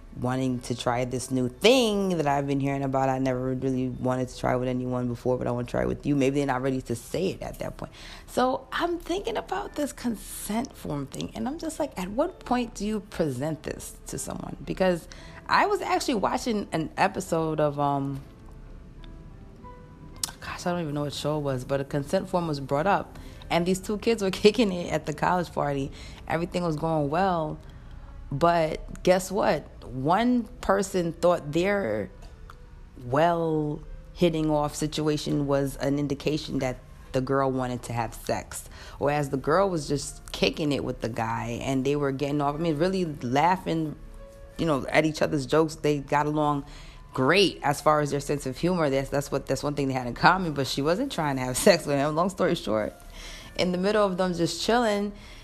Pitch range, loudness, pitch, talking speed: 135-180 Hz, -27 LUFS, 150 Hz, 200 wpm